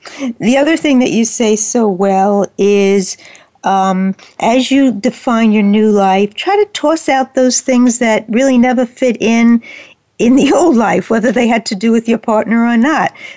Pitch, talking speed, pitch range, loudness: 235 Hz, 185 wpm, 210-260 Hz, -11 LUFS